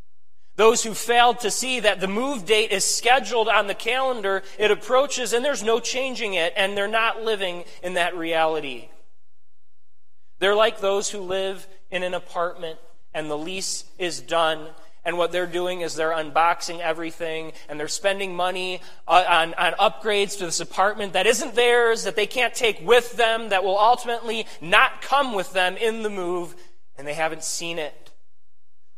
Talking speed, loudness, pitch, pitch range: 170 wpm, -22 LUFS, 185 Hz, 165-220 Hz